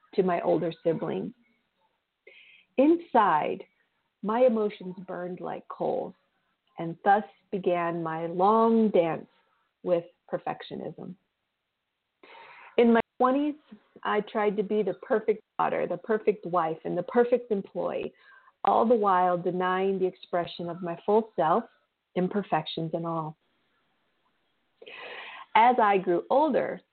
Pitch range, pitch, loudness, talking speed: 175-235 Hz, 200 Hz, -27 LUFS, 115 wpm